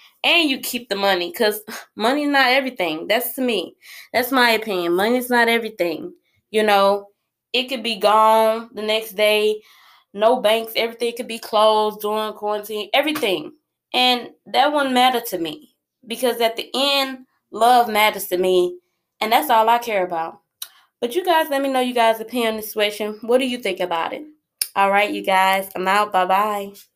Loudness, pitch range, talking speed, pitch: -19 LUFS, 200-250 Hz, 180 wpm, 220 Hz